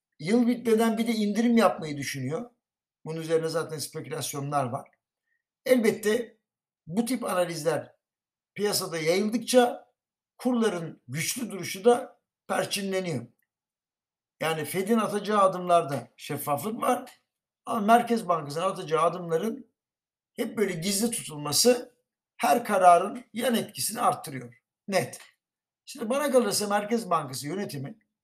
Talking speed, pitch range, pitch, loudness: 110 wpm, 160-235 Hz, 200 Hz, -27 LUFS